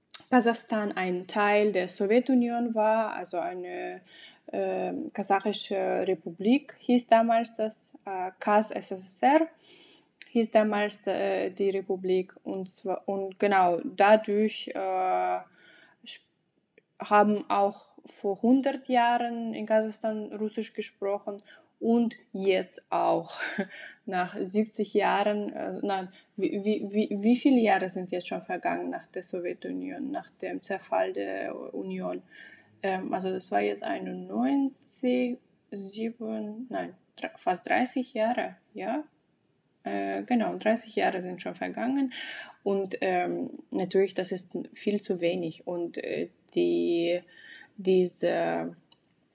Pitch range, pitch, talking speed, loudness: 185-235 Hz, 210 Hz, 115 wpm, -29 LUFS